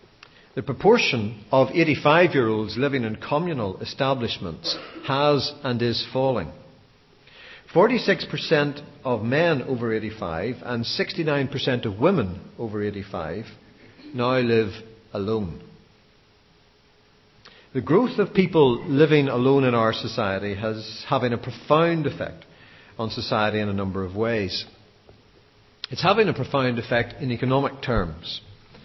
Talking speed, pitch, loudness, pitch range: 120 wpm, 125 Hz, -23 LUFS, 110-145 Hz